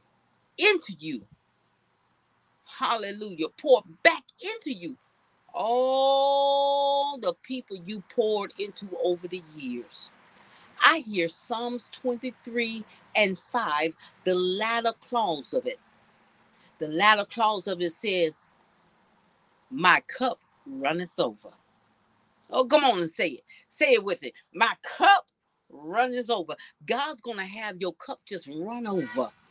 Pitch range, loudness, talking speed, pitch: 185-270 Hz, -26 LUFS, 120 wpm, 225 Hz